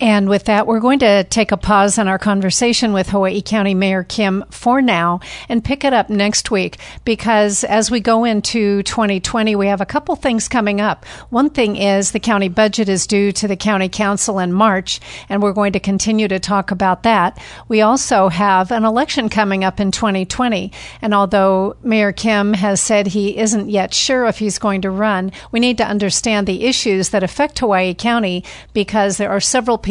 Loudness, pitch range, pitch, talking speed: -15 LUFS, 195-225 Hz, 205 Hz, 200 wpm